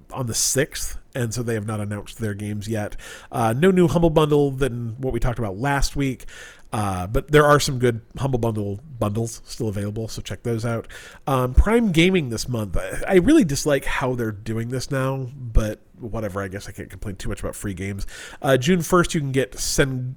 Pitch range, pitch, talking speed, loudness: 105-140 Hz, 120 Hz, 215 wpm, -22 LUFS